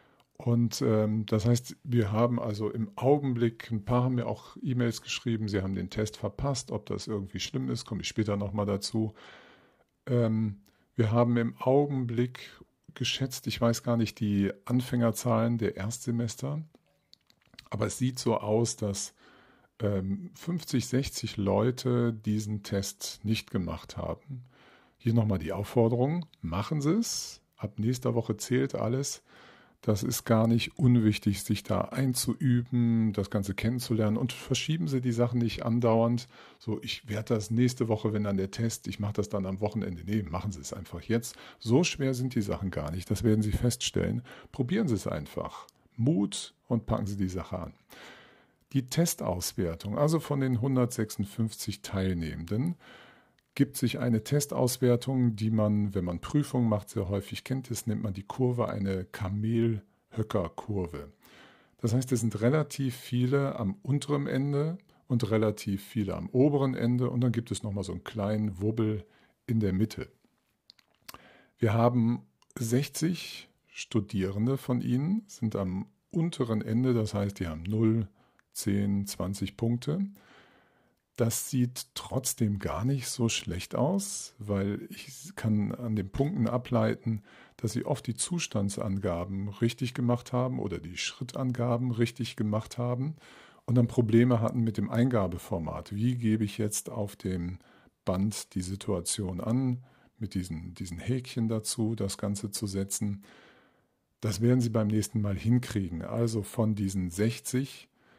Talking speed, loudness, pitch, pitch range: 150 wpm, -30 LUFS, 115 Hz, 105-125 Hz